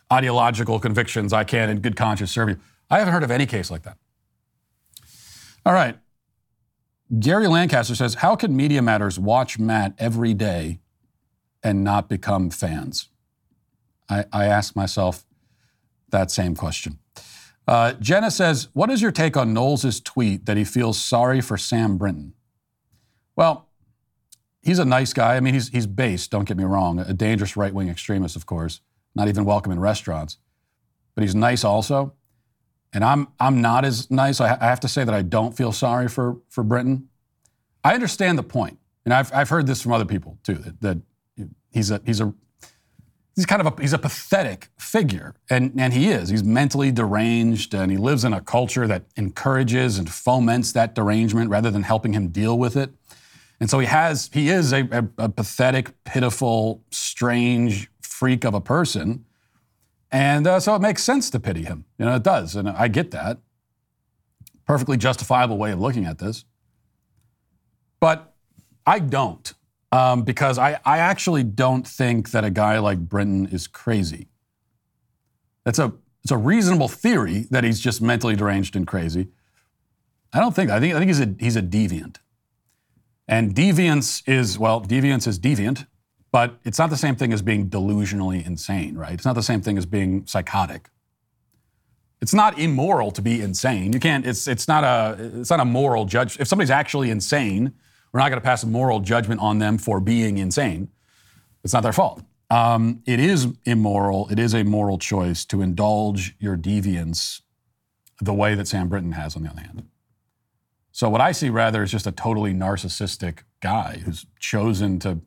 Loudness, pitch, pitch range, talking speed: -21 LUFS, 115 Hz, 100-130 Hz, 180 wpm